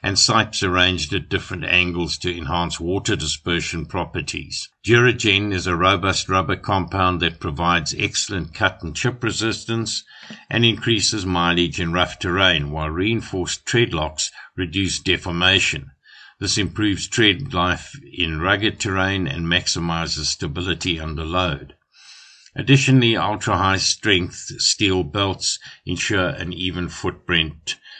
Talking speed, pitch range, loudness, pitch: 120 wpm, 85-105 Hz, -20 LUFS, 90 Hz